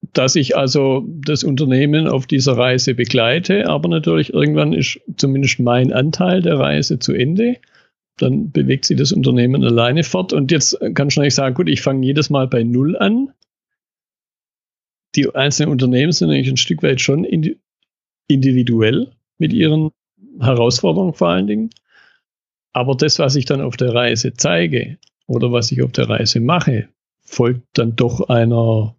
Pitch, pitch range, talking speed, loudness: 135 Hz, 120-155 Hz, 160 wpm, -15 LUFS